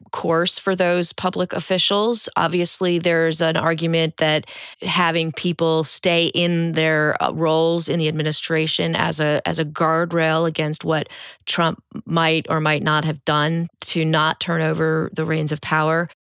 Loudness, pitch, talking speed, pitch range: -20 LUFS, 160 Hz, 150 wpm, 155-170 Hz